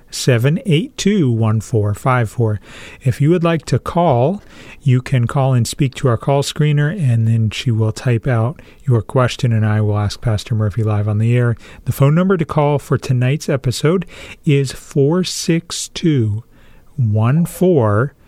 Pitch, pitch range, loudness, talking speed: 130 Hz, 115-150 Hz, -16 LUFS, 175 wpm